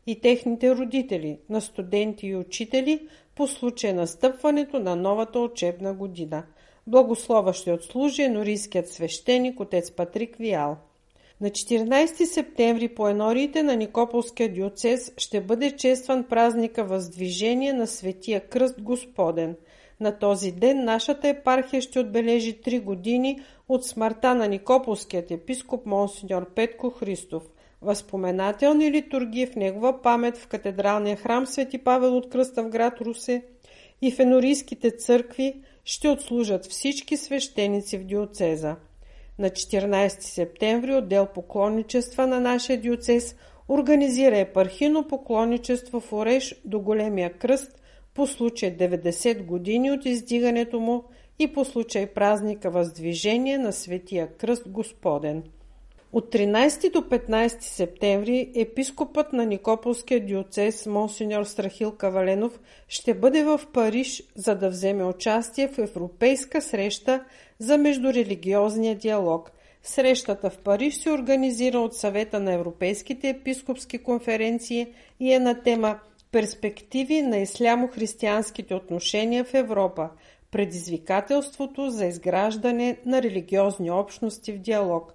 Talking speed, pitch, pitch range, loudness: 120 wpm, 230 Hz, 200-255 Hz, -25 LUFS